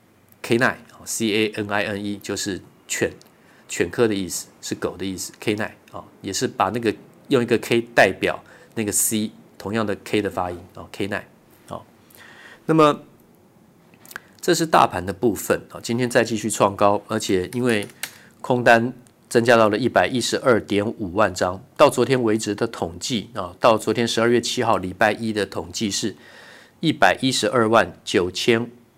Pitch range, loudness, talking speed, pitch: 100-120 Hz, -21 LUFS, 250 characters per minute, 110 Hz